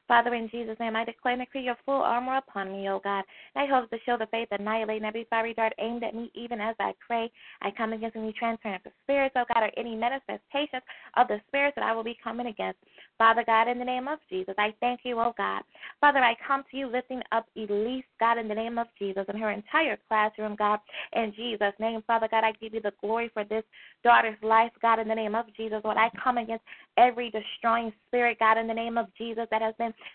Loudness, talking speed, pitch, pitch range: -28 LUFS, 240 wpm, 230 Hz, 220-240 Hz